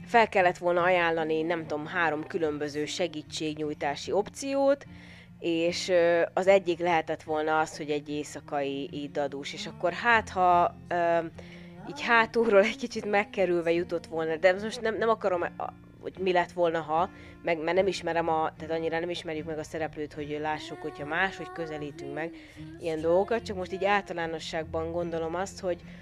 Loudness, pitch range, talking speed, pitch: -28 LUFS, 155-185 Hz, 160 wpm, 170 Hz